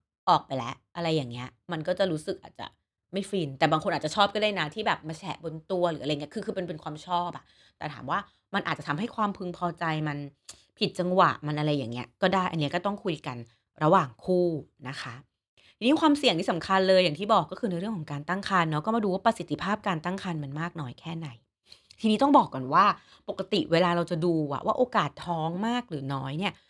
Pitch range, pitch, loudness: 150-195 Hz, 175 Hz, -28 LUFS